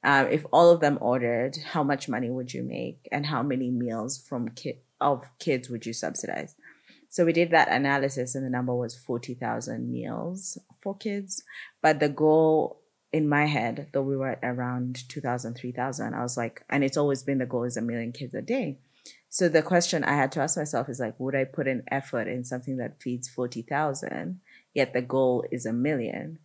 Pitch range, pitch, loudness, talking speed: 125-150 Hz, 130 Hz, -27 LUFS, 205 wpm